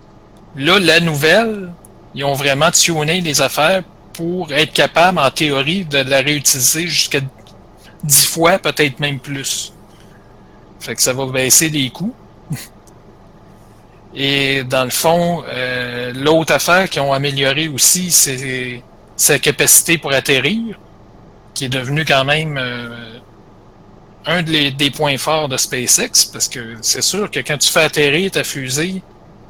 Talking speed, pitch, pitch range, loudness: 145 wpm, 140 Hz, 130-160 Hz, -14 LUFS